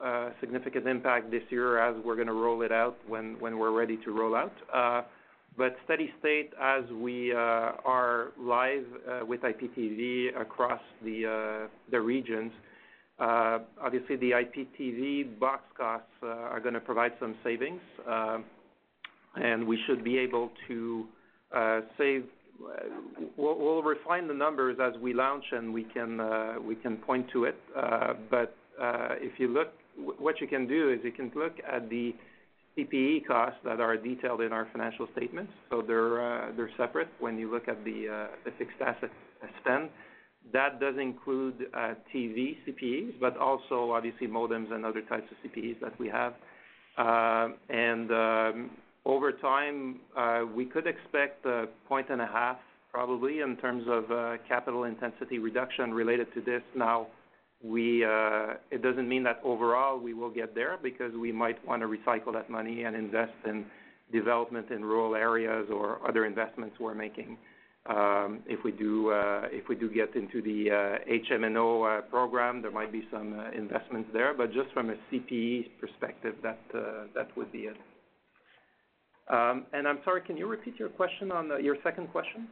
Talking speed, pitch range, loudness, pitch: 175 wpm, 115-125 Hz, -32 LUFS, 120 Hz